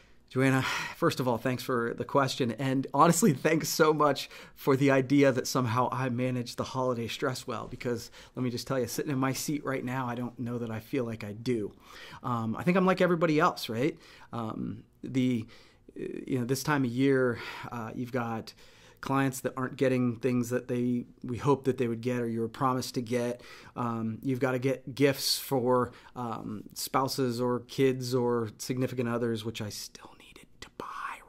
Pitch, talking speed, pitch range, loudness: 130 Hz, 190 wpm, 120-135 Hz, -30 LUFS